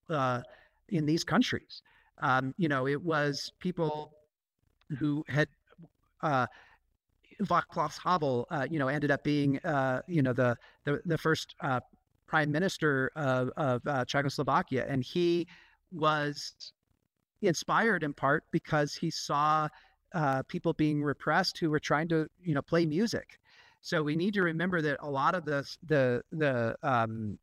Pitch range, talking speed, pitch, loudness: 140-165 Hz, 150 wpm, 150 Hz, -31 LUFS